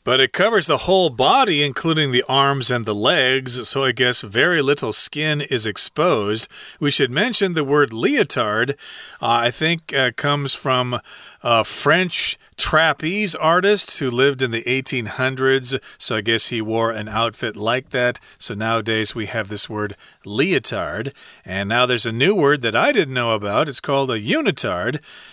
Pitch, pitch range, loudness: 130 Hz, 115-145 Hz, -18 LUFS